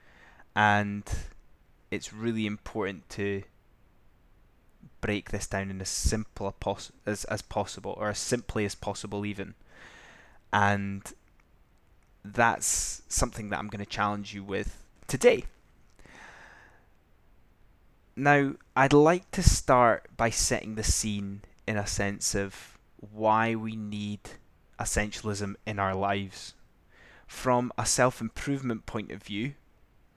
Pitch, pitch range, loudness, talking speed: 105 Hz, 100-110 Hz, -29 LUFS, 115 wpm